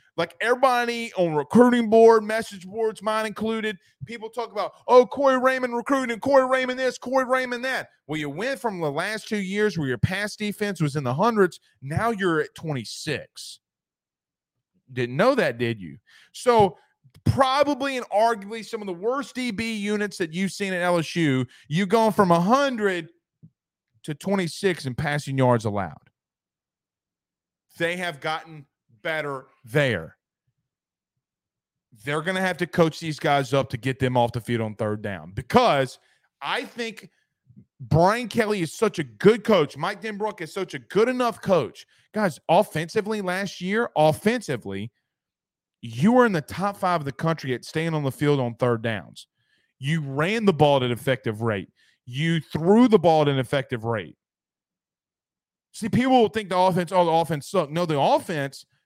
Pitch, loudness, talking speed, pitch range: 175 Hz, -23 LUFS, 165 wpm, 140-220 Hz